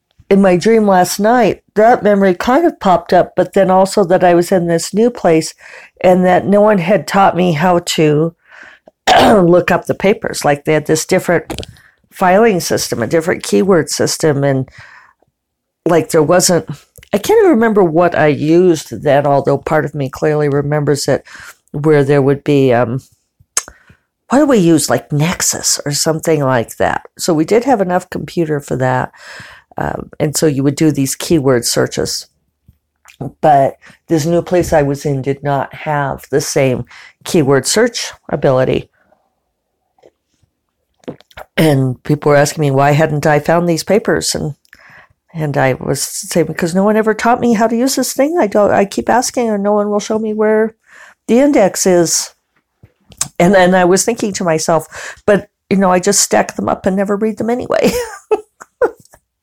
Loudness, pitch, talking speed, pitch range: -13 LUFS, 170 Hz, 175 wpm, 145-205 Hz